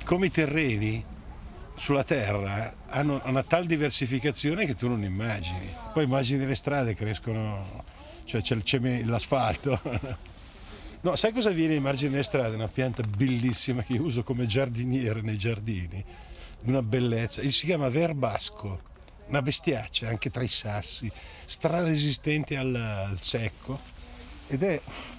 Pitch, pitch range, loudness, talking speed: 120 Hz, 105-140 Hz, -28 LUFS, 150 wpm